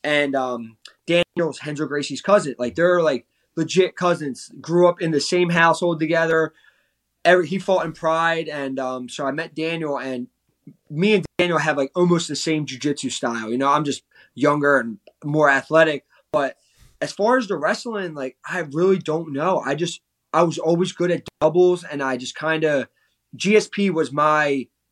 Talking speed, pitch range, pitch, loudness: 180 wpm, 140-175 Hz, 160 Hz, -21 LUFS